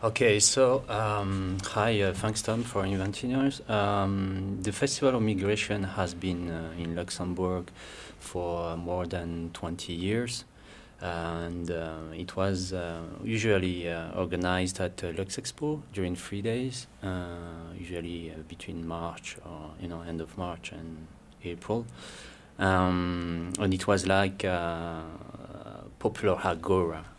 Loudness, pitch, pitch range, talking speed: -30 LUFS, 90 Hz, 85-105 Hz, 135 wpm